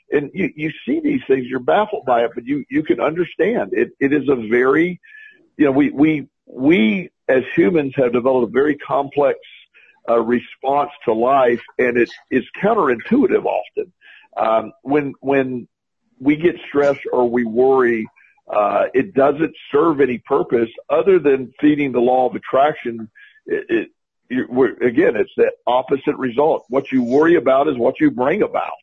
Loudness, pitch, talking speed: -18 LUFS, 160 Hz, 170 wpm